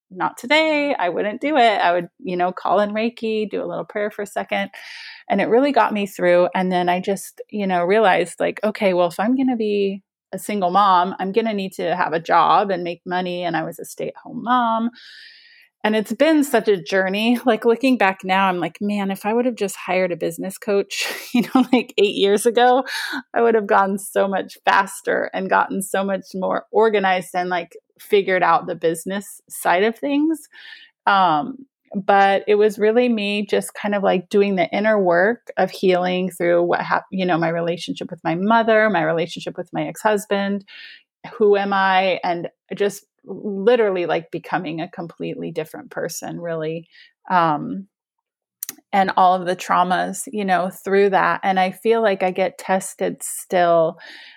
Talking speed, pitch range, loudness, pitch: 195 wpm, 180-230 Hz, -19 LUFS, 200 Hz